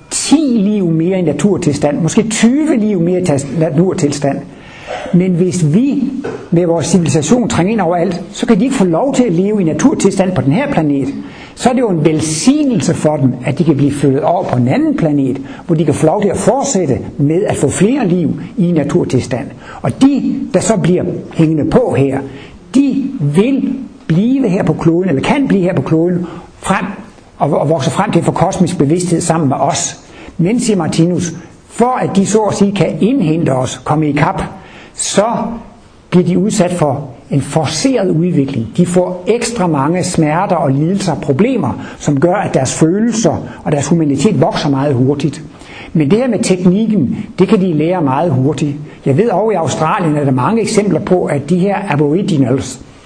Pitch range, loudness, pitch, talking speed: 150-205 Hz, -13 LUFS, 175 Hz, 190 wpm